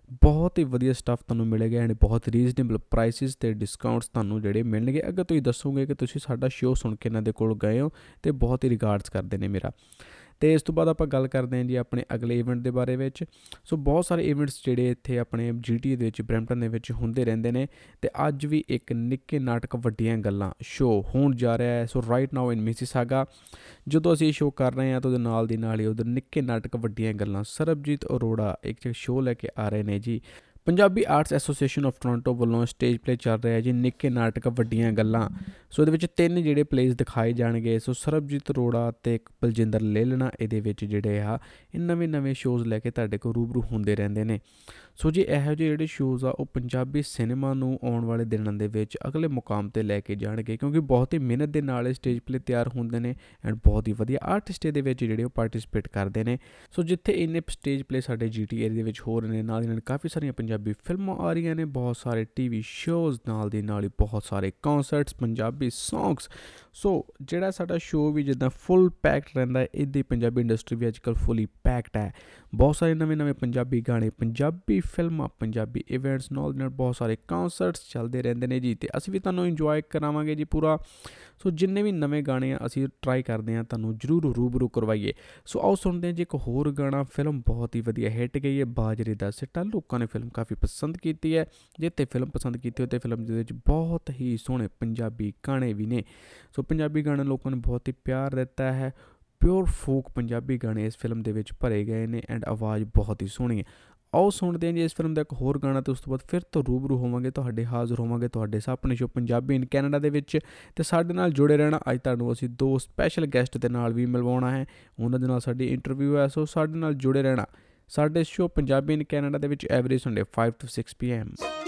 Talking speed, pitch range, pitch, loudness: 215 wpm, 115-145 Hz, 125 Hz, -27 LUFS